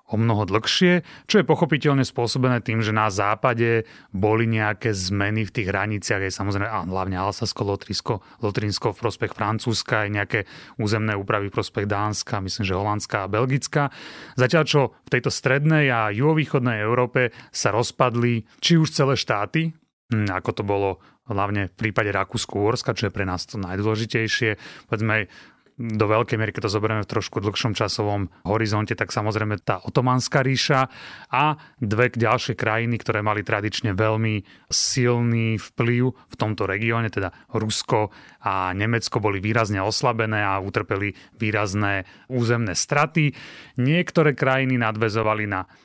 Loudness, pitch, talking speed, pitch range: -23 LUFS, 110 Hz, 145 wpm, 105-125 Hz